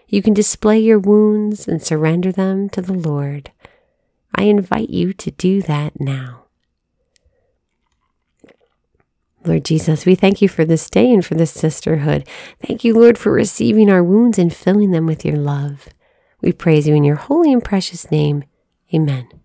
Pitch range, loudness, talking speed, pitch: 150-210 Hz, -15 LUFS, 165 wpm, 180 Hz